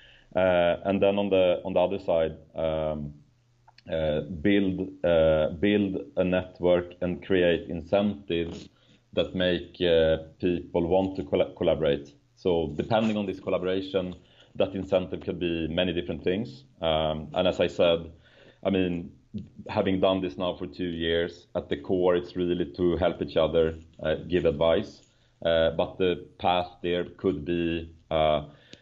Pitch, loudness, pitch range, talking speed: 90 Hz, -27 LUFS, 80-95 Hz, 150 wpm